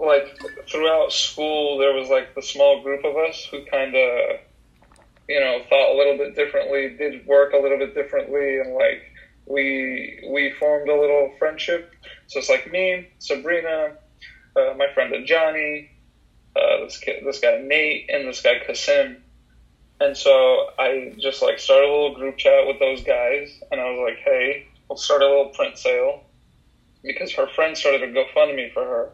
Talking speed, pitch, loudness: 185 wpm, 160 Hz, -20 LUFS